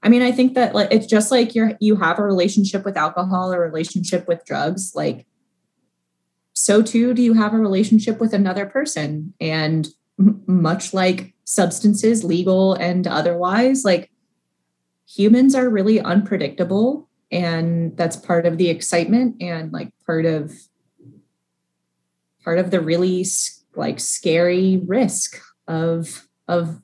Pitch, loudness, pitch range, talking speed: 185 Hz, -18 LUFS, 165-215 Hz, 140 wpm